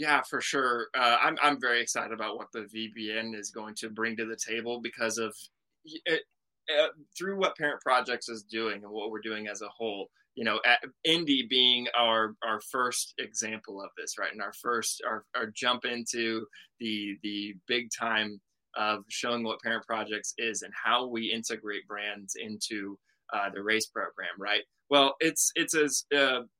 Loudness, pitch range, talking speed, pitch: -30 LUFS, 110-125 Hz, 180 wpm, 115 Hz